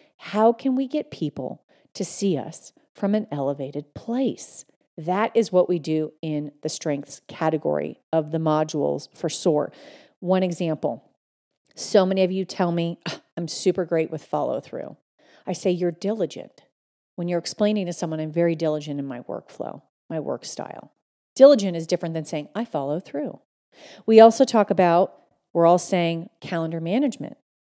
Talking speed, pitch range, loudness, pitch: 160 wpm, 160-205 Hz, -23 LUFS, 175 Hz